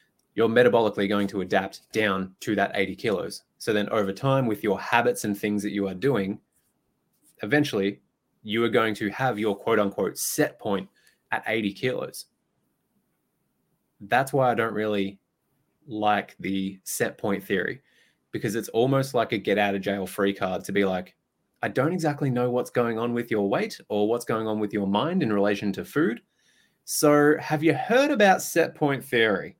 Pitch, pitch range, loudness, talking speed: 105 Hz, 100-125 Hz, -25 LUFS, 180 wpm